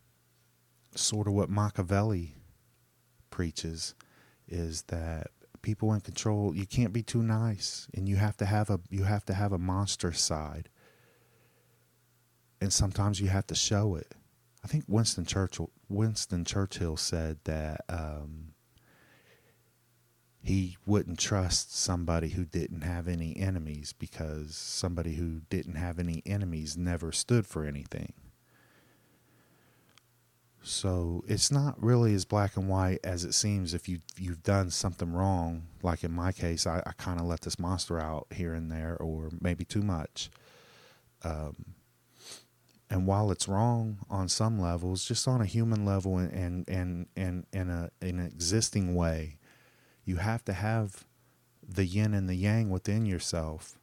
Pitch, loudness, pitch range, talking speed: 95 Hz, -32 LUFS, 85-105 Hz, 145 wpm